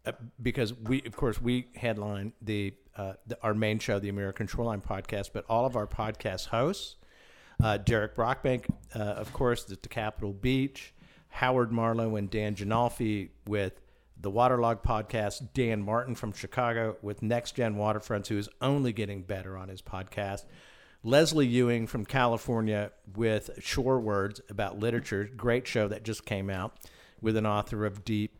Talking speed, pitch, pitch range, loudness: 165 wpm, 110 Hz, 105-120 Hz, -31 LUFS